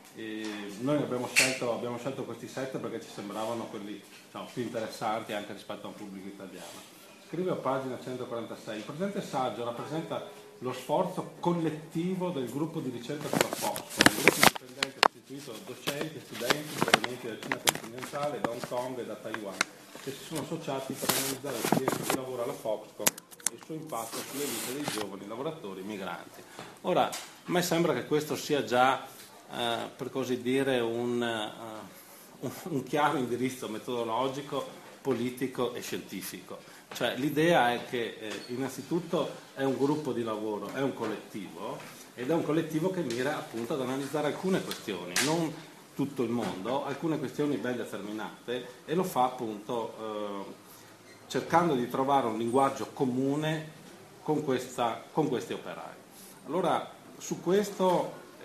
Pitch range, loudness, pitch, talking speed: 115-150 Hz, -31 LUFS, 130 Hz, 155 wpm